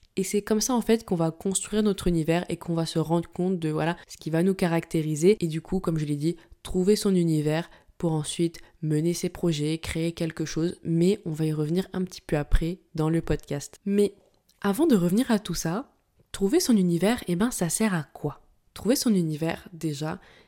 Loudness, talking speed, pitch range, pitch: -26 LUFS, 220 wpm, 160-195 Hz, 170 Hz